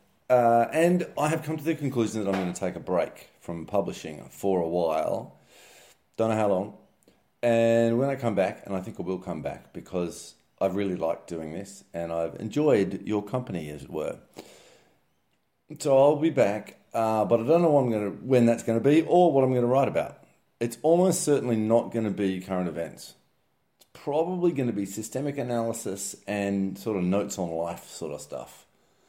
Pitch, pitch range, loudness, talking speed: 115 Hz, 95-135 Hz, -26 LUFS, 205 wpm